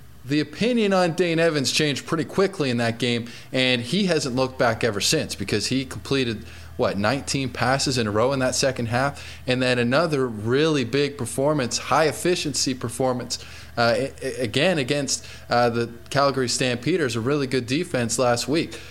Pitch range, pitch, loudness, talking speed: 120-145 Hz, 130 Hz, -23 LUFS, 170 wpm